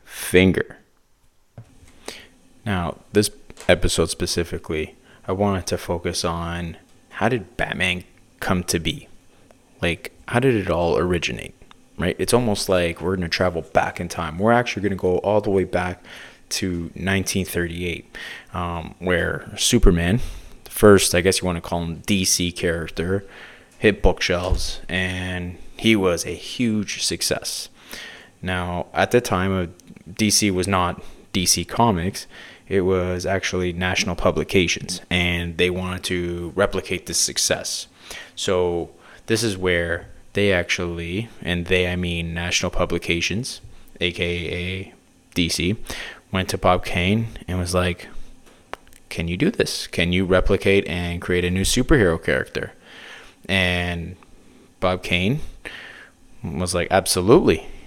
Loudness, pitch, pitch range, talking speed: -21 LUFS, 90 Hz, 85-95 Hz, 130 wpm